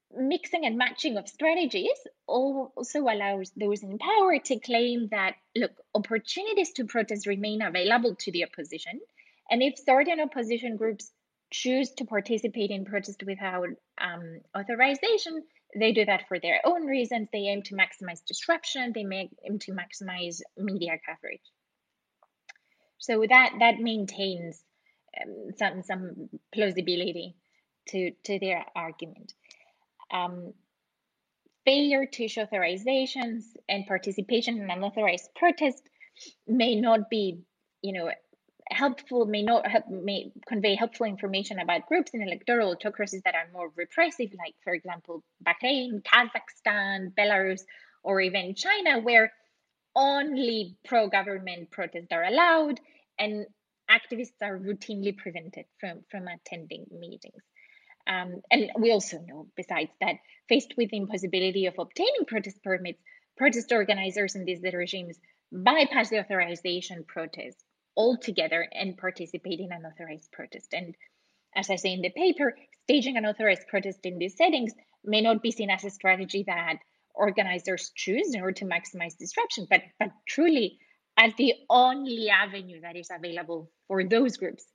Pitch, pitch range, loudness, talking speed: 210 Hz, 185-245 Hz, -27 LUFS, 140 wpm